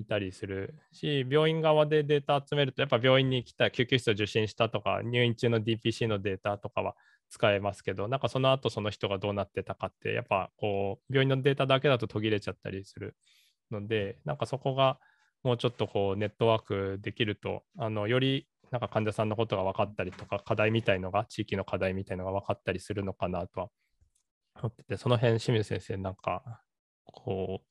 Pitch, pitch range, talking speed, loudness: 110 Hz, 100-125 Hz, 415 characters per minute, -30 LUFS